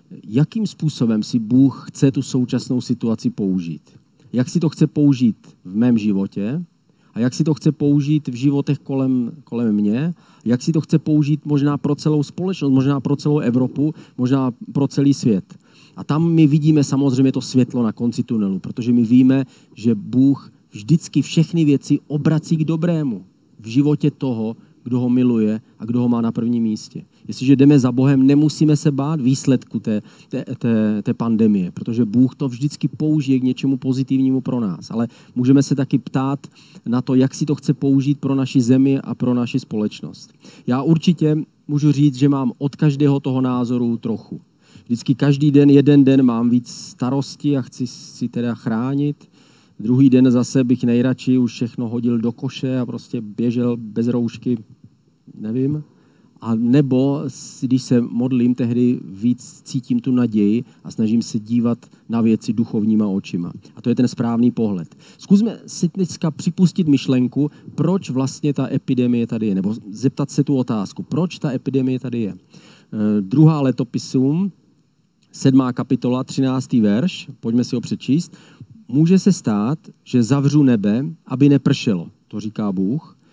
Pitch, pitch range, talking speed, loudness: 135 Hz, 120-150 Hz, 165 wpm, -18 LUFS